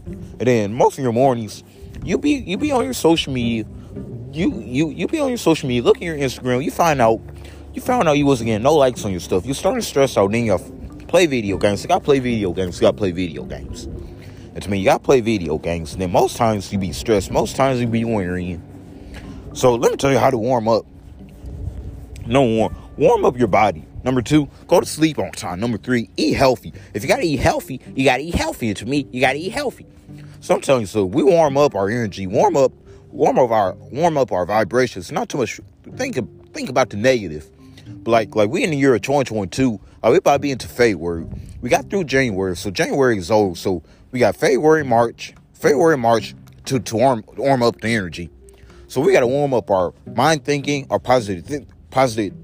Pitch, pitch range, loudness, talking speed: 115 Hz, 95-135 Hz, -18 LUFS, 230 wpm